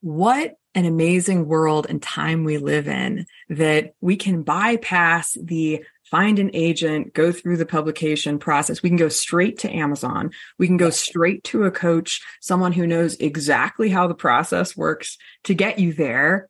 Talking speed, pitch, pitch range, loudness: 170 wpm, 170 Hz, 155-185 Hz, -20 LUFS